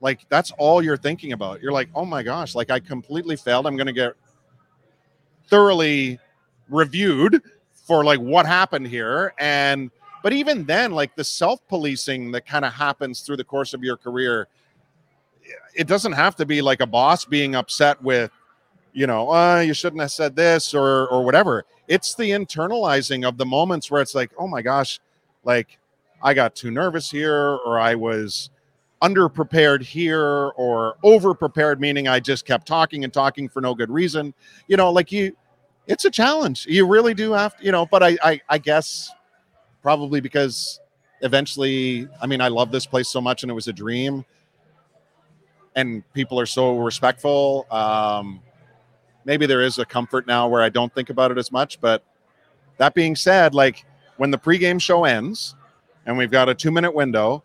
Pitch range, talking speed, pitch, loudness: 130-165 Hz, 185 wpm, 140 Hz, -20 LUFS